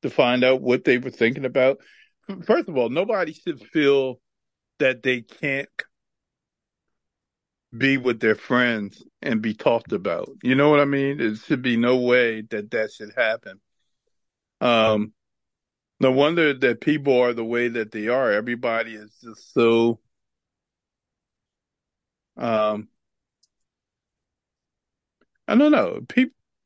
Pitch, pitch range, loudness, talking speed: 125 Hz, 110-135 Hz, -21 LUFS, 135 wpm